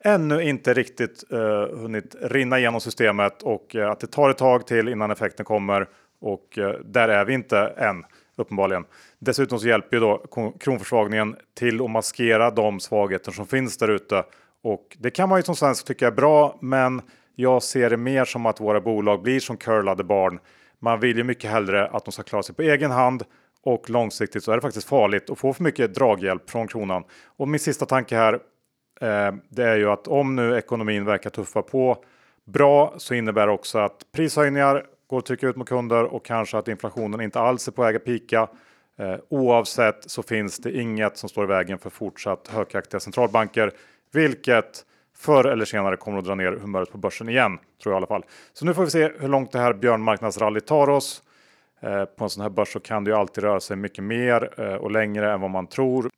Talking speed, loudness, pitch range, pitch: 205 wpm, -23 LUFS, 105-130 Hz, 115 Hz